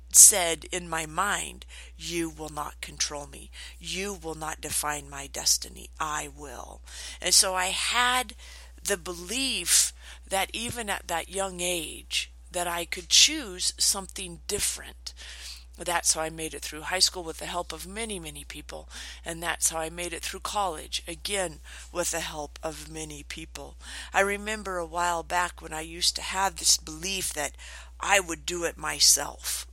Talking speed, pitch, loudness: 170 wpm, 160 Hz, -26 LUFS